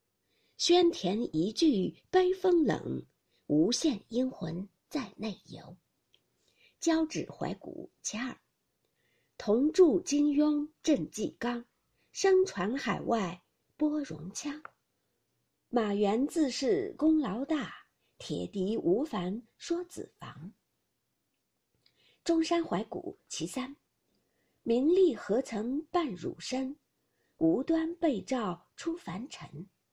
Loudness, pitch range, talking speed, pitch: -31 LUFS, 225-330 Hz, 135 characters per minute, 290 Hz